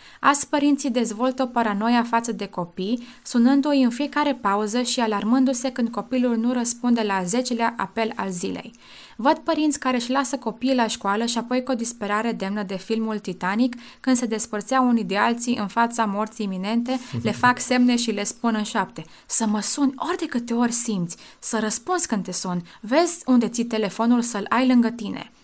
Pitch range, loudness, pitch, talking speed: 215-255 Hz, -22 LUFS, 235 Hz, 185 wpm